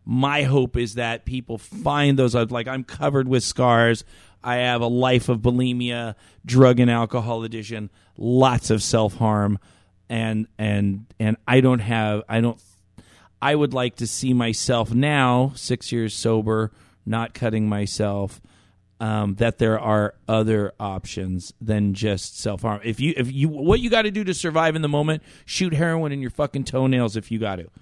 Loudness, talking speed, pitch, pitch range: -22 LUFS, 175 wpm, 115 Hz, 105-125 Hz